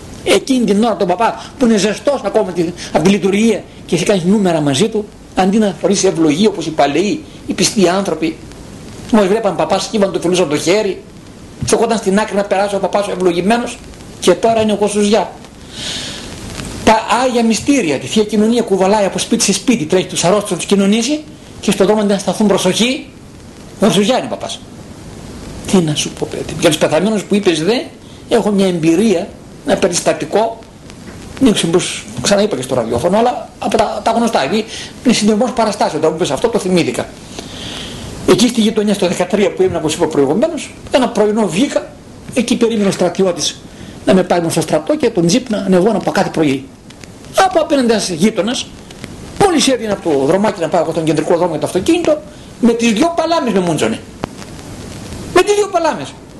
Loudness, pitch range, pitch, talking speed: -14 LUFS, 180-230 Hz, 205 Hz, 185 wpm